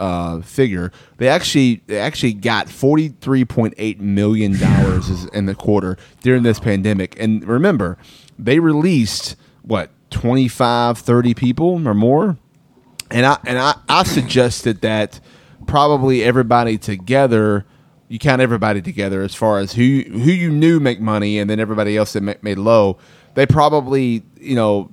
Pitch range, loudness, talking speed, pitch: 105-135 Hz, -16 LUFS, 150 wpm, 120 Hz